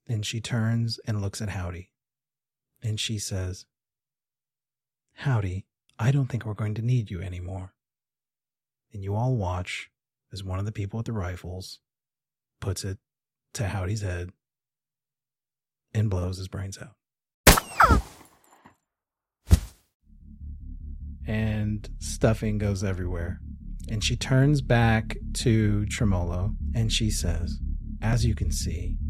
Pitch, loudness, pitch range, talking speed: 110 Hz, -27 LUFS, 95-130 Hz, 120 wpm